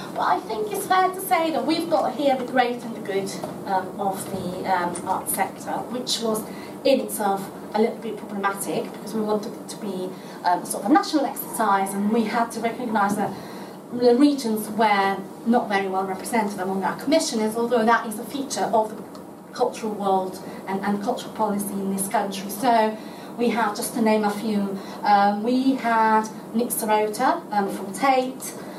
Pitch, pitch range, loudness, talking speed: 220 Hz, 200-240 Hz, -23 LUFS, 190 wpm